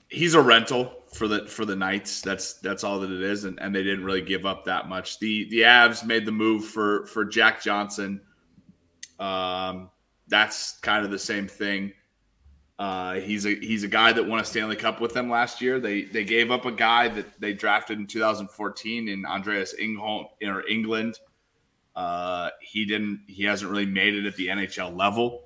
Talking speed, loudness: 195 wpm, -24 LUFS